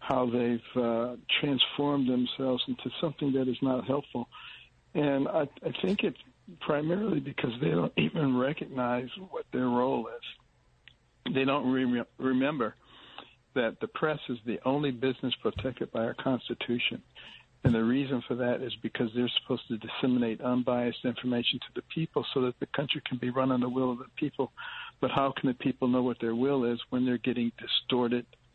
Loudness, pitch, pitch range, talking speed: -30 LUFS, 130 Hz, 120-135 Hz, 175 wpm